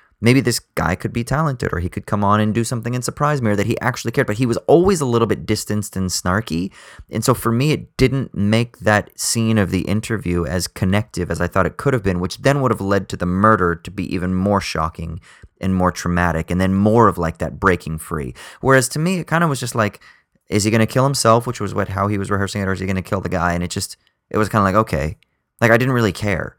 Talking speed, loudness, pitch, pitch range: 275 wpm, -18 LUFS, 105 Hz, 90-120 Hz